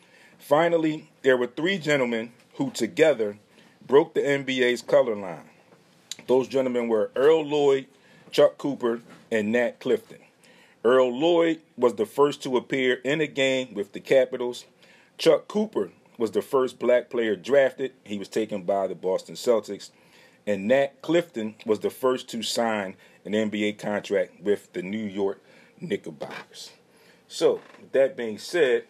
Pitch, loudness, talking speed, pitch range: 130 Hz, -25 LUFS, 145 wpm, 115-155 Hz